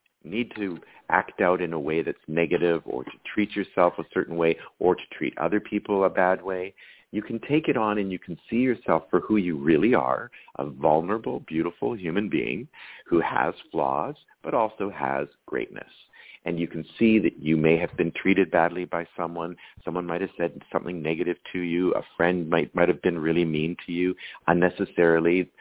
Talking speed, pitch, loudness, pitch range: 195 wpm, 90 Hz, -26 LUFS, 85-95 Hz